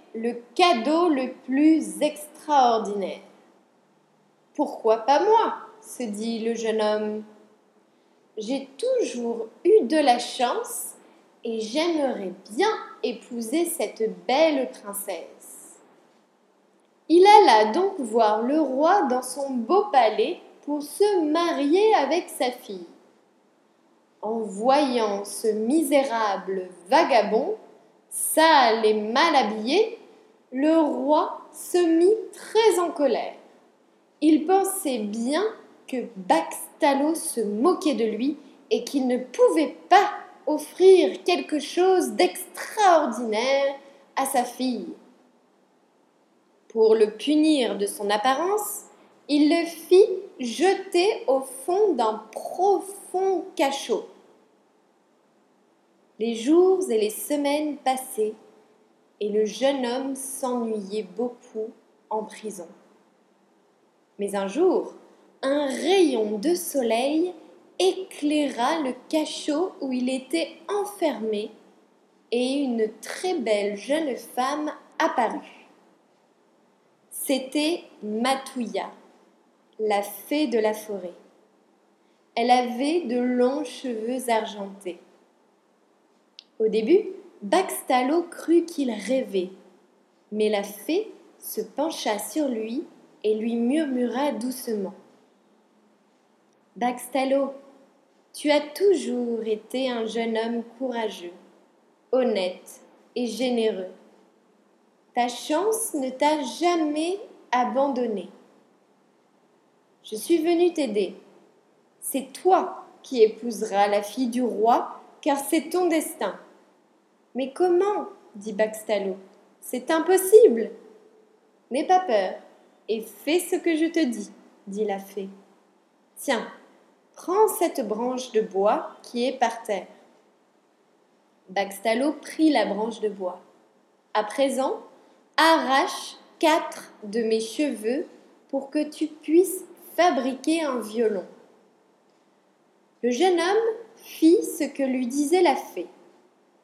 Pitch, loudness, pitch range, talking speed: 270 Hz, -24 LUFS, 225-330 Hz, 105 wpm